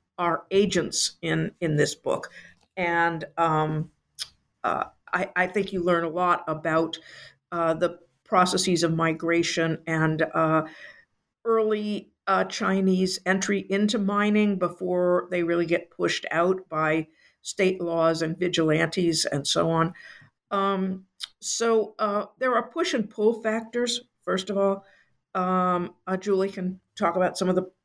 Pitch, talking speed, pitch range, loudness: 180 Hz, 140 wpm, 165-200 Hz, -25 LUFS